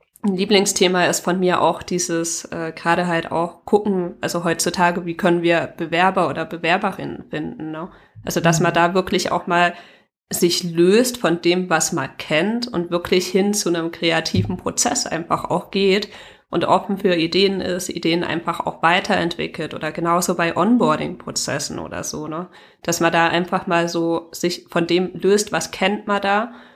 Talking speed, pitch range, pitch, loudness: 170 wpm, 170-190 Hz, 175 Hz, -19 LUFS